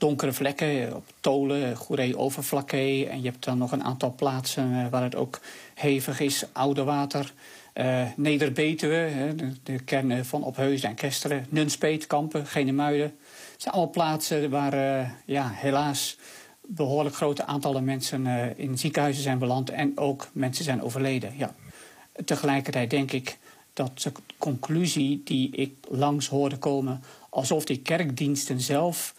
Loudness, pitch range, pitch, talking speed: -27 LUFS, 130-145 Hz, 140 Hz, 145 wpm